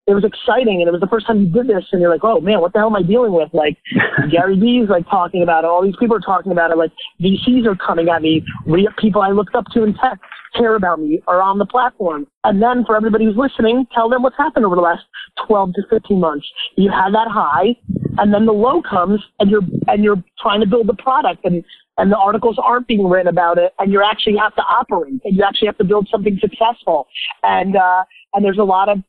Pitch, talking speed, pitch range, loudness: 205 Hz, 255 wpm, 180-225 Hz, -15 LUFS